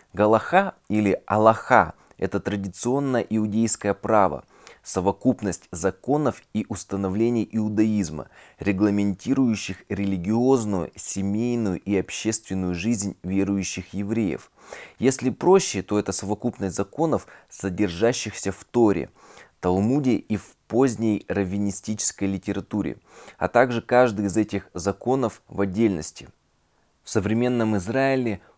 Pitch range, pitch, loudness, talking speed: 95-115 Hz, 105 Hz, -24 LUFS, 95 wpm